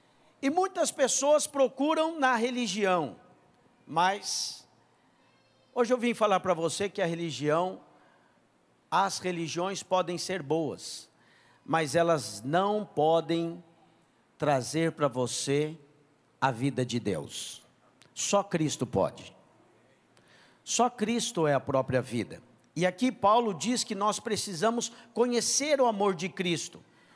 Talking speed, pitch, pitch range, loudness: 115 wpm, 180 Hz, 150-235 Hz, -29 LUFS